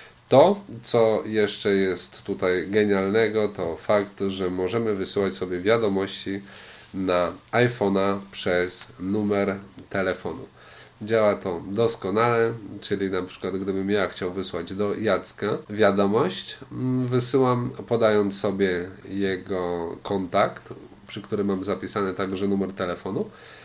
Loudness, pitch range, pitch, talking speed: -24 LUFS, 95-105 Hz, 100 Hz, 110 wpm